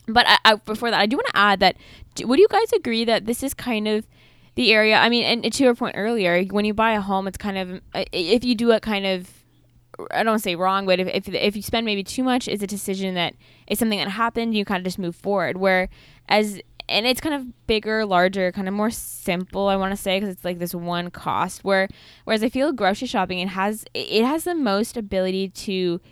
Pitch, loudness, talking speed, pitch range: 205 Hz, -21 LUFS, 250 wpm, 185-230 Hz